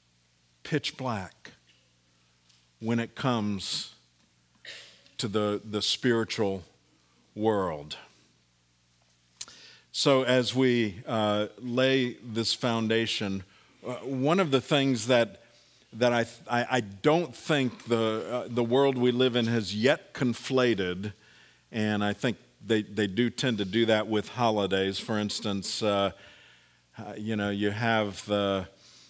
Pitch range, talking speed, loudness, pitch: 95-120 Hz, 120 wpm, -28 LUFS, 110 Hz